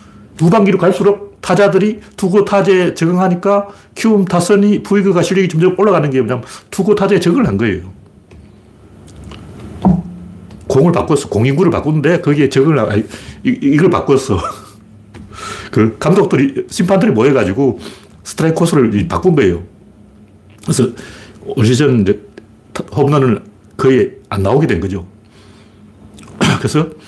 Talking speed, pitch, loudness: 285 characters per minute, 150 Hz, -13 LUFS